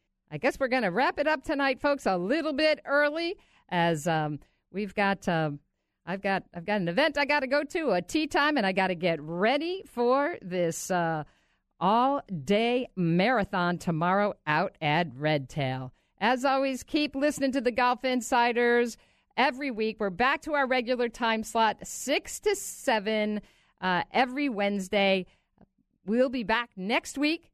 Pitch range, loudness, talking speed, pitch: 185-275 Hz, -27 LUFS, 160 wpm, 230 Hz